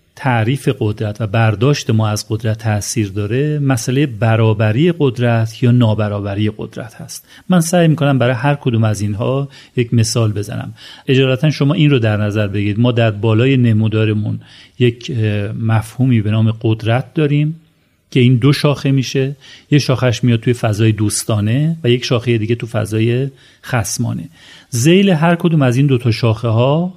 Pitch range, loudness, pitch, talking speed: 110-140 Hz, -15 LUFS, 120 Hz, 160 wpm